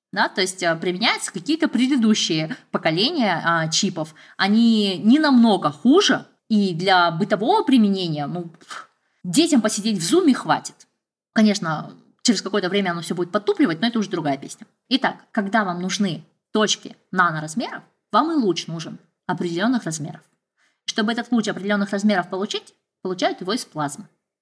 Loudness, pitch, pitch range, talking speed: -20 LUFS, 205 Hz, 175-235 Hz, 145 wpm